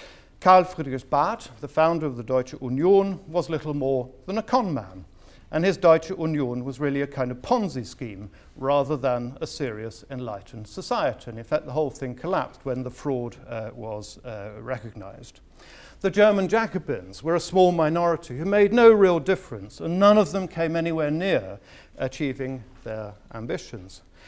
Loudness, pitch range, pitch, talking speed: -24 LUFS, 120-170 Hz, 140 Hz, 170 wpm